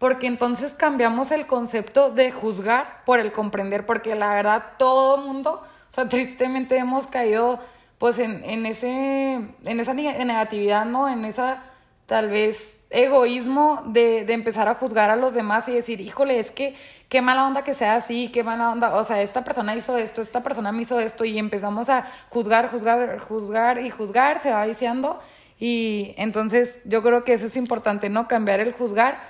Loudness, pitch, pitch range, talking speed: -22 LUFS, 240 Hz, 220-255 Hz, 180 wpm